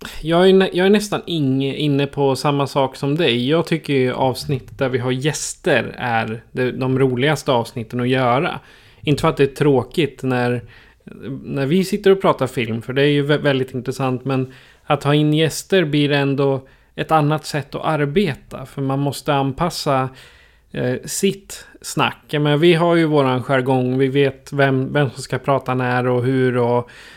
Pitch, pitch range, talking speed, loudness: 140 Hz, 130-150 Hz, 180 wpm, -18 LUFS